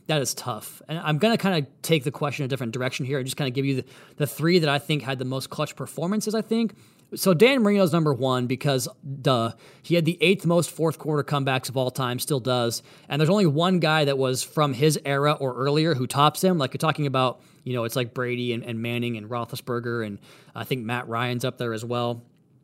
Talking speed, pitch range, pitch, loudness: 245 wpm, 125-155 Hz, 140 Hz, -24 LUFS